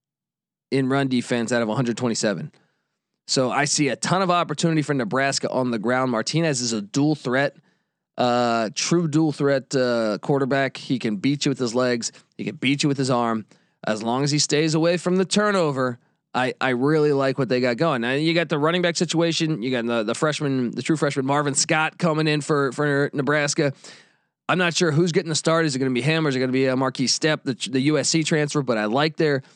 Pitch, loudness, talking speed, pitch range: 140 Hz, -22 LUFS, 225 wpm, 125-160 Hz